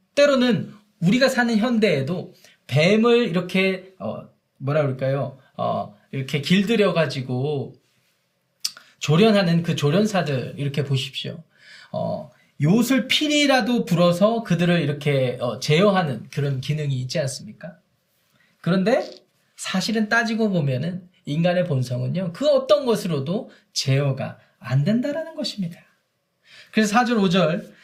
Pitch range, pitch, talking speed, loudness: 145-220 Hz, 180 Hz, 270 characters per minute, -21 LUFS